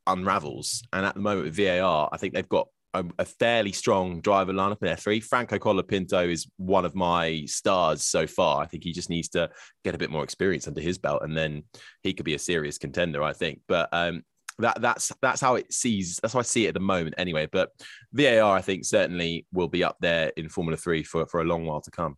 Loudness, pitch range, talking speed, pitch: -26 LUFS, 80-95 Hz, 240 wpm, 85 Hz